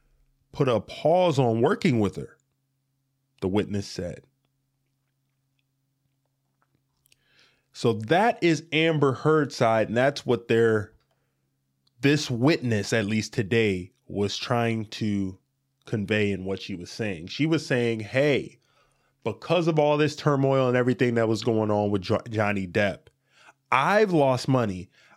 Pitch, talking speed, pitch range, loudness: 125 Hz, 130 wpm, 105-135 Hz, -24 LUFS